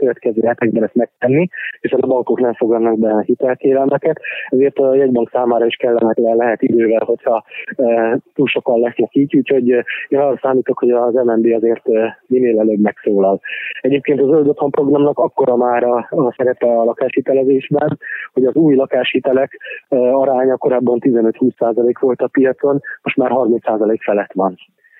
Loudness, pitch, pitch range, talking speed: -15 LUFS, 125 Hz, 115-135 Hz, 150 wpm